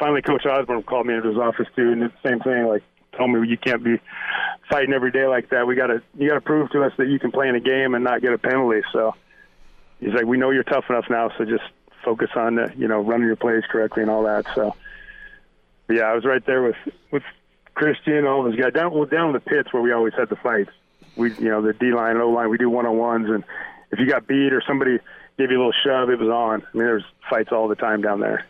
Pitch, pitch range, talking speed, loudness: 120 Hz, 115-135 Hz, 260 wpm, -21 LUFS